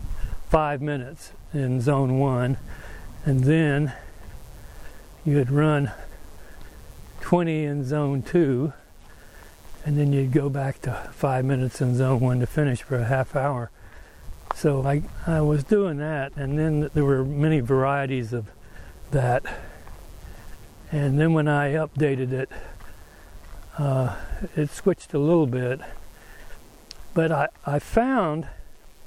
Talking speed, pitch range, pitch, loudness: 125 wpm, 120-150 Hz, 140 Hz, -24 LUFS